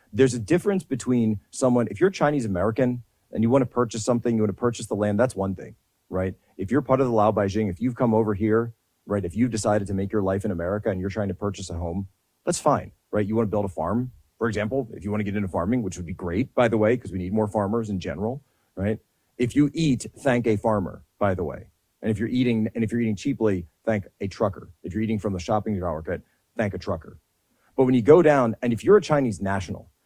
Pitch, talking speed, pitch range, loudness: 110 Hz, 260 wpm, 100-125 Hz, -24 LUFS